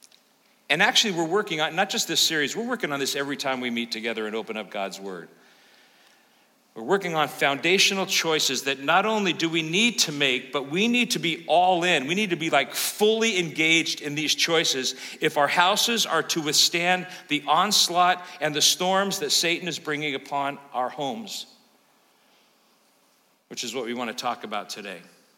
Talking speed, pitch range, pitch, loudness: 190 wpm, 140-185 Hz, 165 Hz, -23 LUFS